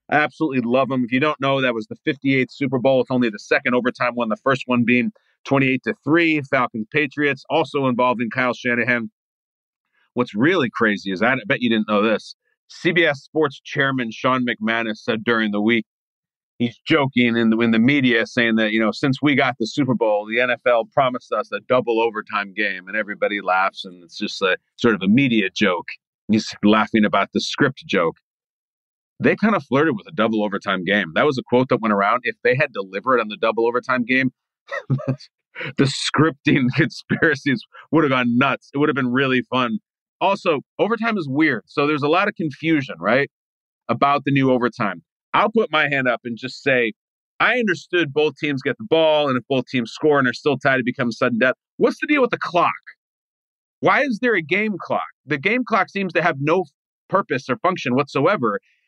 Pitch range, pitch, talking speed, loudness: 115-150 Hz, 130 Hz, 205 wpm, -20 LUFS